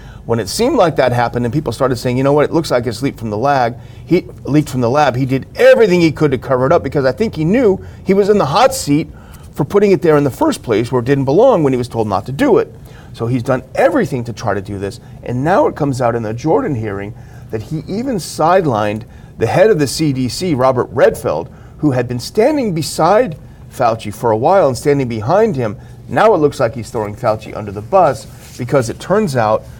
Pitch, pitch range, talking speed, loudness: 135 Hz, 120-160 Hz, 245 wpm, -14 LUFS